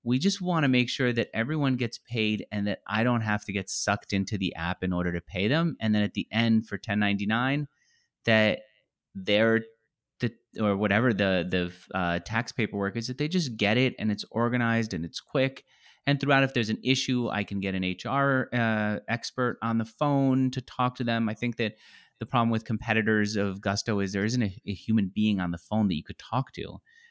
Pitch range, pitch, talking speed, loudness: 100-125 Hz, 110 Hz, 225 wpm, -27 LUFS